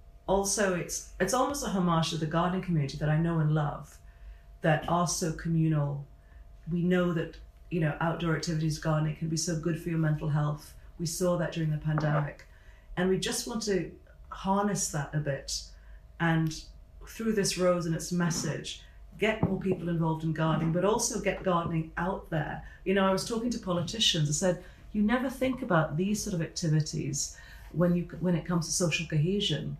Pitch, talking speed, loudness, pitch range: 165 Hz, 190 wpm, -30 LUFS, 155-185 Hz